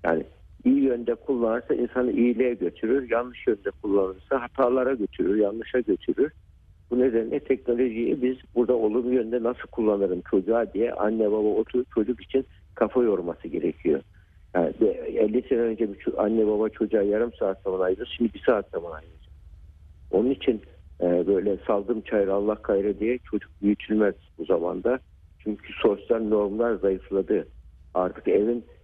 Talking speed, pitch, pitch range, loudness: 145 wpm, 110 Hz, 95-120 Hz, -25 LUFS